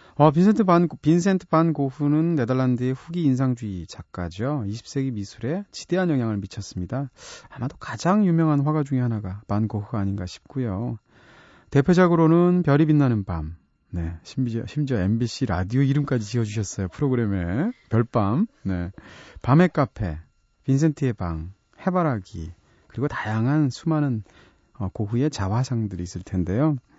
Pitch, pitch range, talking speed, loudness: 125 Hz, 100-150 Hz, 320 characters per minute, -23 LUFS